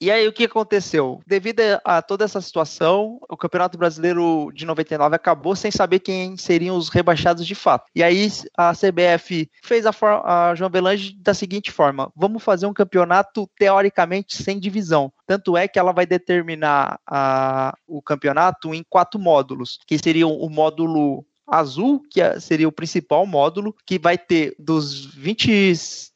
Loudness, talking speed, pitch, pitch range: -19 LUFS, 165 wpm, 175 Hz, 160-200 Hz